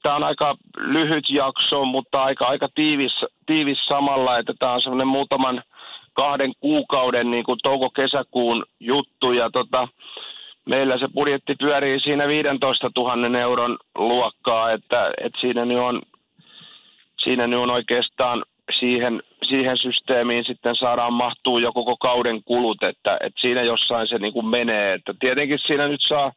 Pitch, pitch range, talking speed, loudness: 125 Hz, 120-135 Hz, 145 wpm, -21 LUFS